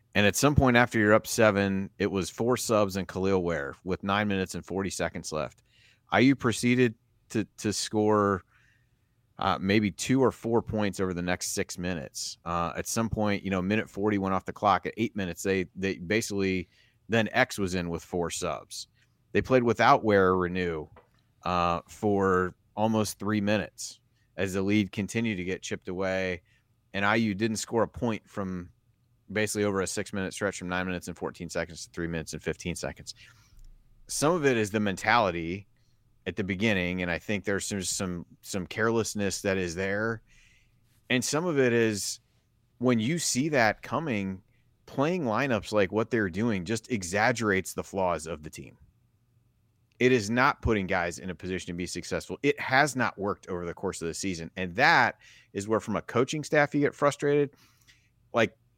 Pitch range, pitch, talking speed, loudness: 95-115 Hz, 105 Hz, 185 wpm, -28 LUFS